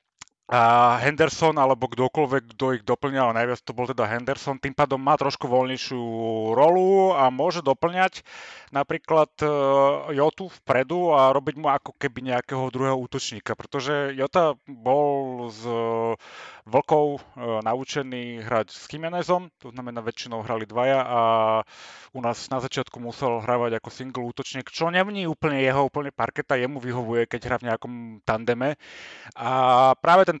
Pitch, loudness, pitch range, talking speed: 130 Hz, -23 LUFS, 120-145 Hz, 140 wpm